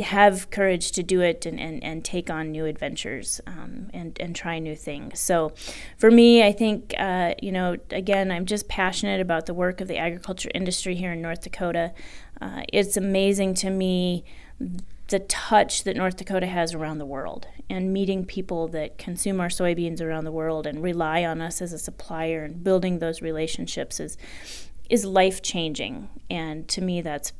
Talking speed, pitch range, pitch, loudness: 180 wpm, 165-195 Hz, 180 Hz, -24 LUFS